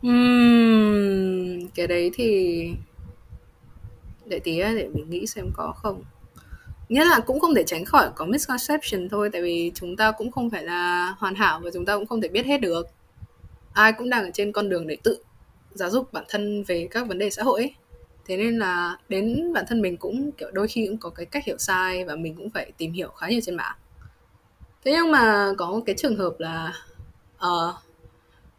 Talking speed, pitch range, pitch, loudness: 205 wpm, 175-230 Hz, 200 Hz, -23 LUFS